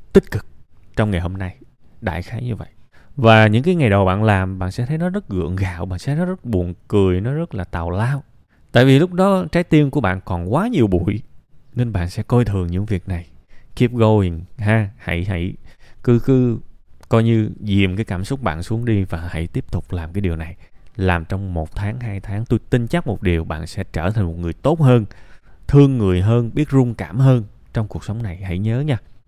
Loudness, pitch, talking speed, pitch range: -19 LUFS, 105 Hz, 230 wpm, 90-120 Hz